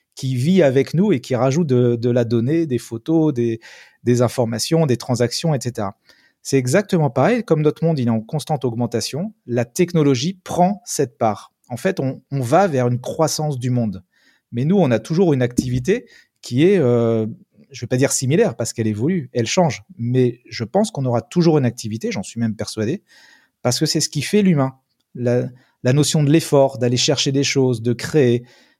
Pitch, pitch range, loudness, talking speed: 130 Hz, 120-160 Hz, -19 LUFS, 200 wpm